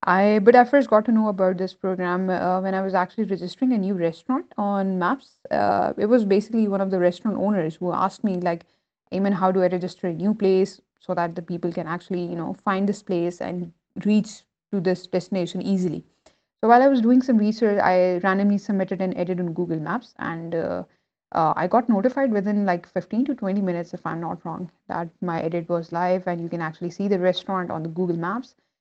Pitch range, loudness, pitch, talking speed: 175-210 Hz, -23 LUFS, 190 Hz, 220 wpm